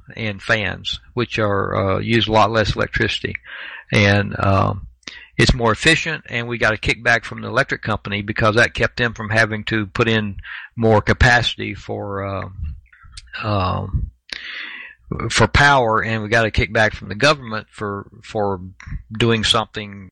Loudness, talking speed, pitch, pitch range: -18 LUFS, 155 wpm, 110 Hz, 100-115 Hz